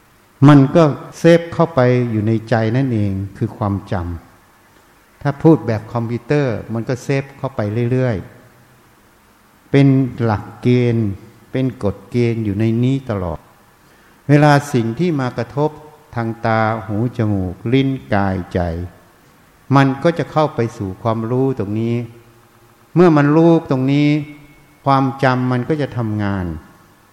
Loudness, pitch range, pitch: -17 LUFS, 110-140 Hz, 120 Hz